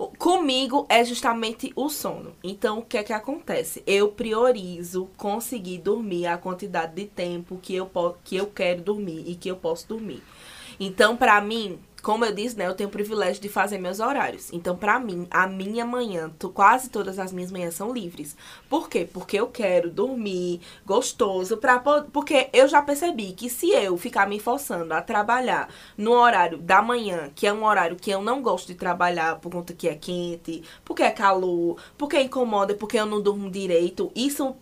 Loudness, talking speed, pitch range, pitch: -24 LUFS, 190 wpm, 180-240 Hz, 205 Hz